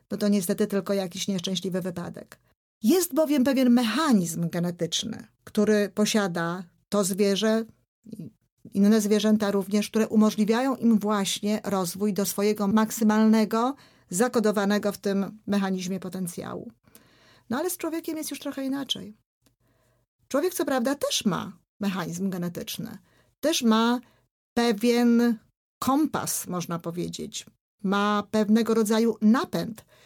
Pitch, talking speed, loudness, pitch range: 210 Hz, 115 wpm, -25 LUFS, 195-230 Hz